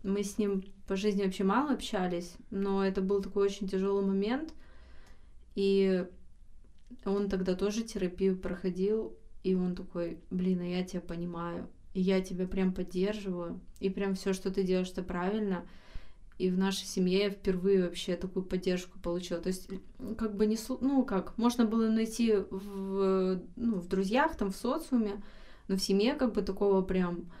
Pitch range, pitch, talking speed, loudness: 185-205 Hz, 195 Hz, 165 wpm, -32 LUFS